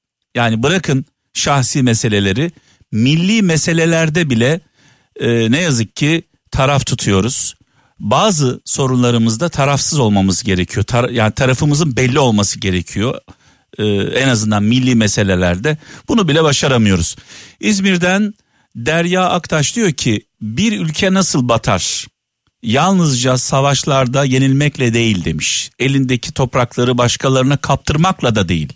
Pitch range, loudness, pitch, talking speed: 115-155 Hz, -14 LUFS, 130 Hz, 110 wpm